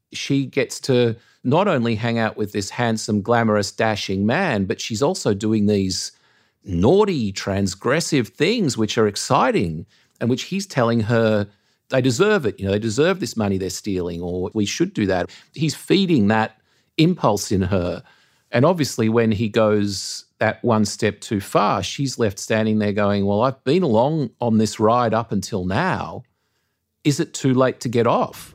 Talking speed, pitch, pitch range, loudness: 175 wpm, 110 Hz, 105-130 Hz, -20 LUFS